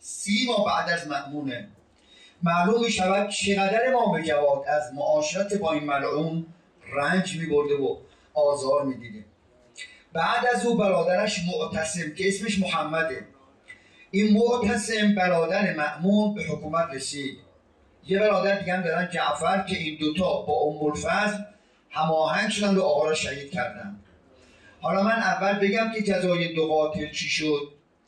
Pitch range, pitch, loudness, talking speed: 150-205 Hz, 170 Hz, -25 LUFS, 140 wpm